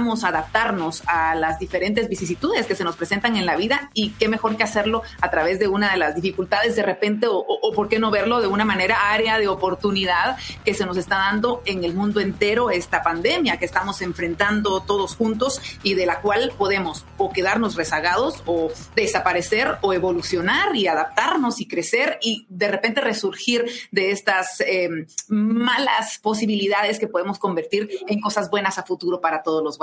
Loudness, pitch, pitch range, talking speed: -21 LUFS, 200 Hz, 180-220 Hz, 185 wpm